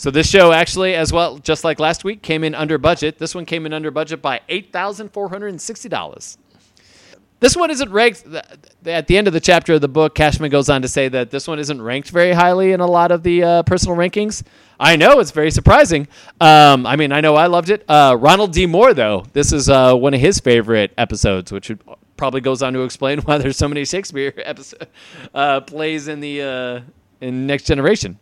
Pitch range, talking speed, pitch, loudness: 135-175 Hz, 215 wpm, 155 Hz, -14 LUFS